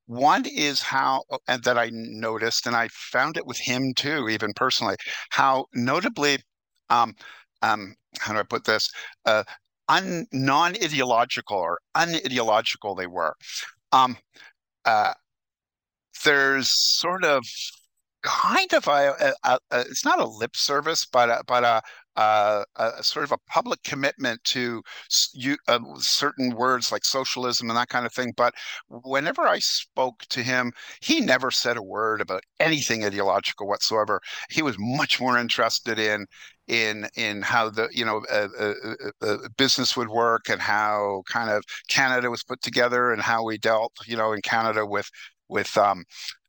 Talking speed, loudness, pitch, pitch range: 160 wpm, -23 LUFS, 120 Hz, 110-130 Hz